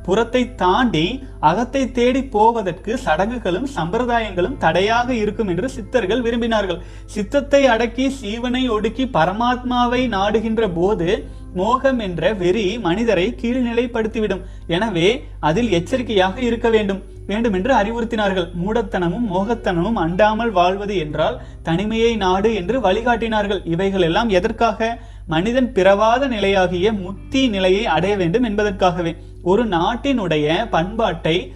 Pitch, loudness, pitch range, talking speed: 215 Hz, -18 LUFS, 185-235 Hz, 105 wpm